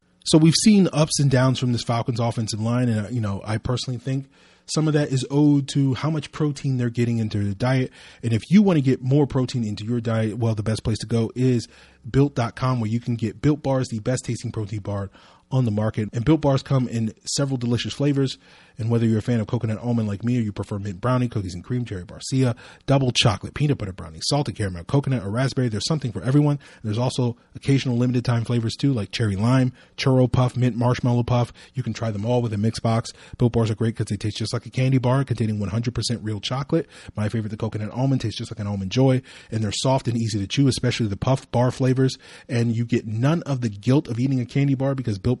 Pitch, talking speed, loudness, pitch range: 120 Hz, 245 wpm, -23 LUFS, 110-130 Hz